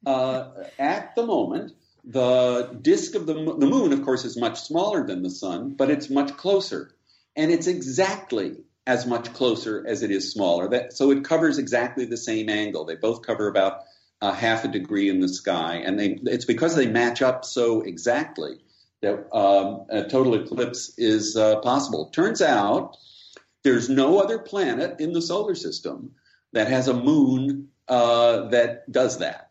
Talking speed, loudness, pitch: 175 wpm, -23 LUFS, 135 Hz